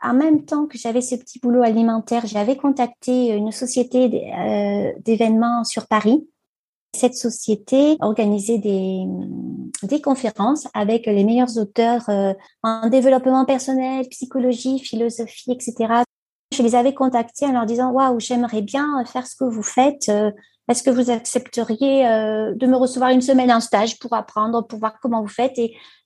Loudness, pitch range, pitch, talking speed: -19 LUFS, 225-260 Hz, 240 Hz, 150 wpm